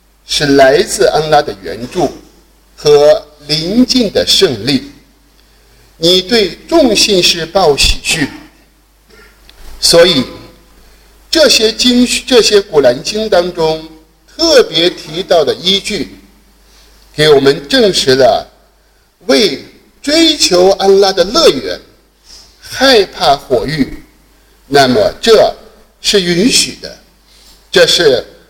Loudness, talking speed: -9 LUFS, 145 characters per minute